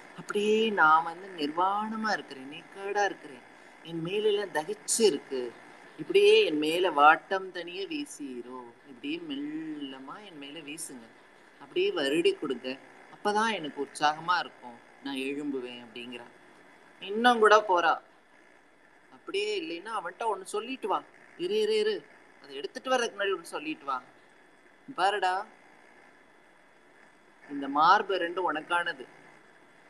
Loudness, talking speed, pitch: -28 LUFS, 105 wpm, 205 Hz